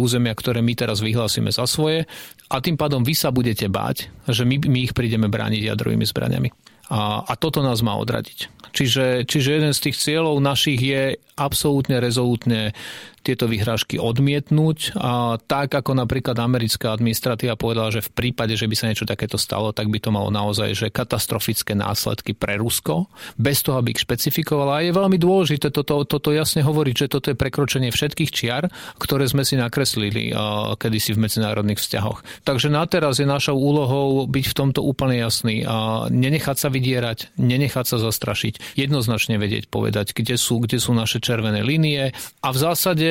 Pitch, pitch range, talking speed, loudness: 125 Hz, 110-140 Hz, 175 wpm, -21 LUFS